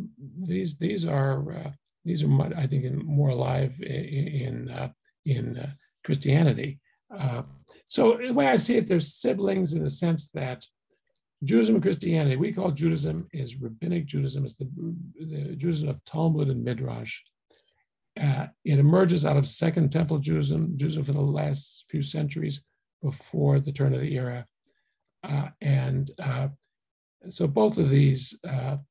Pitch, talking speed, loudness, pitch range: 145 Hz, 155 wpm, -26 LUFS, 140-165 Hz